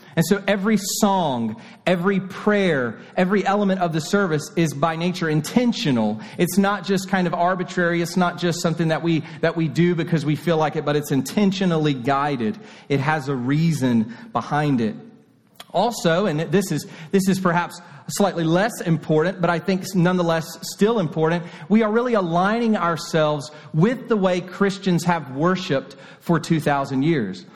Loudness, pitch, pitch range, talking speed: -21 LUFS, 175 Hz, 160-195 Hz, 165 wpm